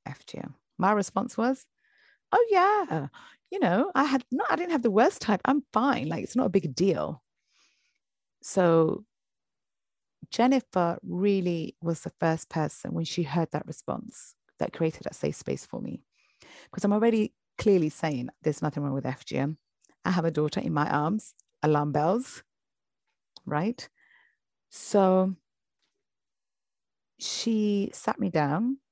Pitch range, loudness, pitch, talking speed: 160-250 Hz, -27 LUFS, 195 Hz, 145 wpm